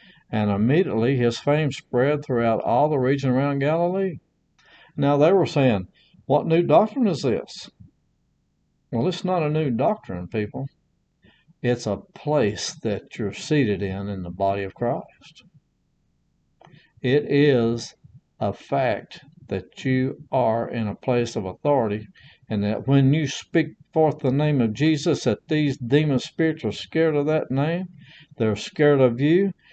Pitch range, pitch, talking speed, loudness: 115-155 Hz, 140 Hz, 150 wpm, -23 LUFS